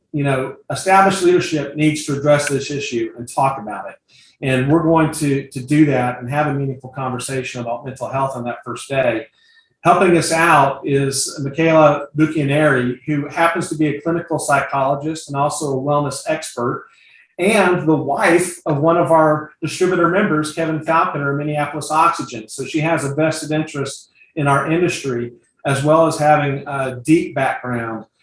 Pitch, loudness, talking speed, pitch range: 150 Hz, -17 LUFS, 170 wpm, 135-160 Hz